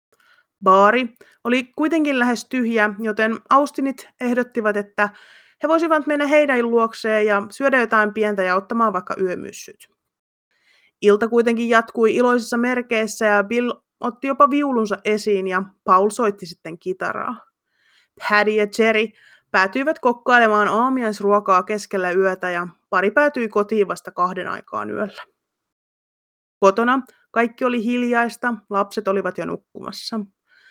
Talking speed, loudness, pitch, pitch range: 120 wpm, -19 LUFS, 225 Hz, 205-245 Hz